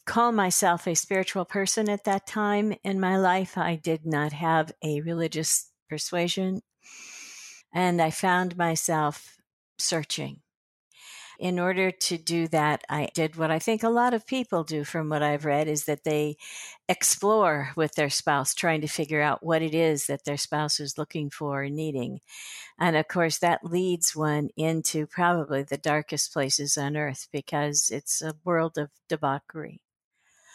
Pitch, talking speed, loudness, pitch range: 160 Hz, 165 wpm, -26 LUFS, 150-180 Hz